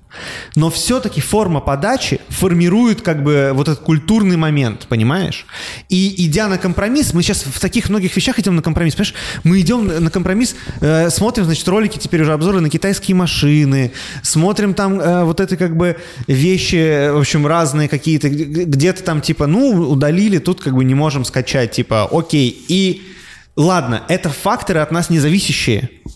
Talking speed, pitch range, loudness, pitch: 165 wpm, 145-190 Hz, -15 LUFS, 165 Hz